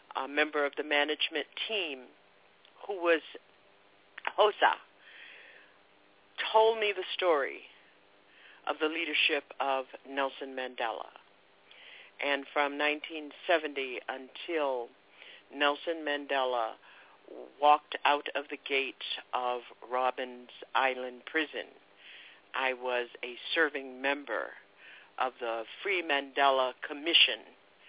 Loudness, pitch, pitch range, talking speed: -31 LUFS, 135 Hz, 125-150 Hz, 95 wpm